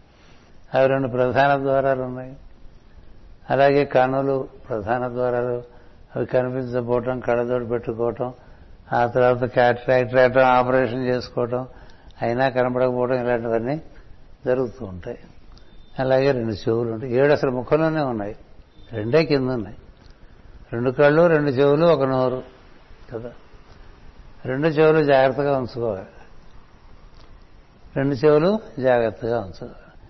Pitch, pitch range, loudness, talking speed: 125 Hz, 120-135 Hz, -21 LUFS, 100 wpm